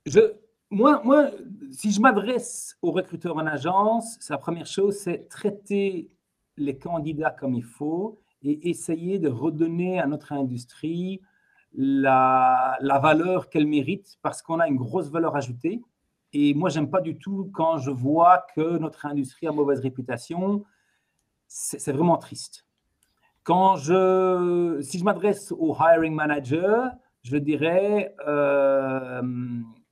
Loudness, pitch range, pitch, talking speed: -24 LUFS, 145-195 Hz, 165 Hz, 140 wpm